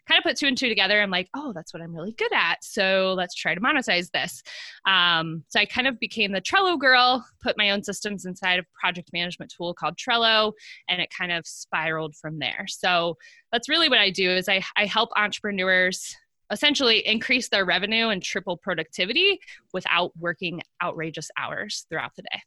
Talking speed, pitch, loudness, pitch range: 200 wpm, 200 Hz, -23 LUFS, 175-235 Hz